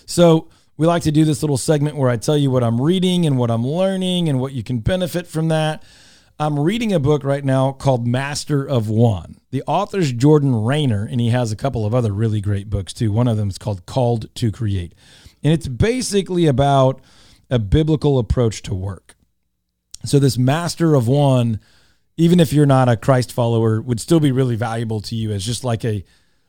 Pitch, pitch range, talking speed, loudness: 130 Hz, 115-150 Hz, 205 wpm, -18 LUFS